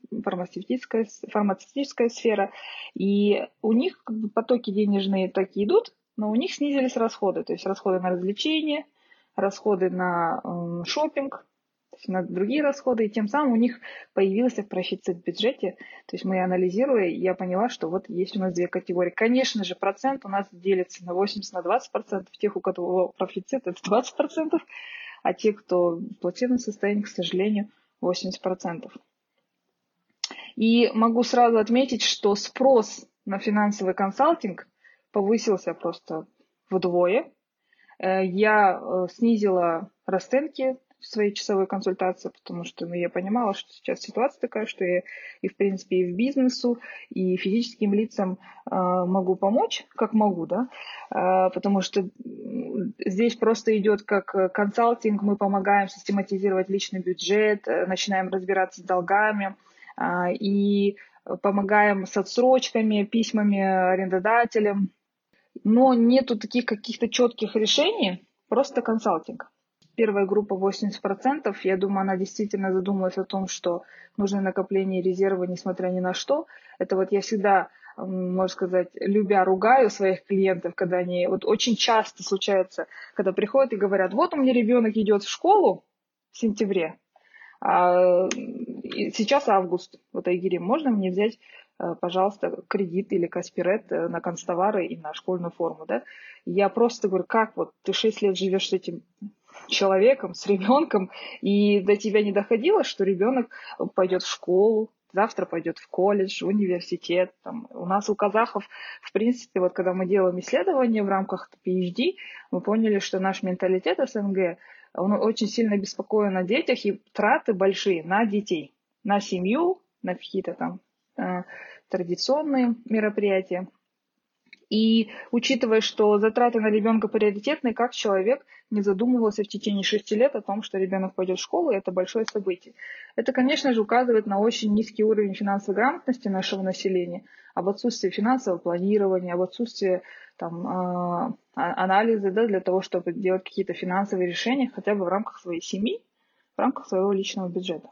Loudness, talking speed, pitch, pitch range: -25 LUFS, 140 wpm, 200 Hz, 185-230 Hz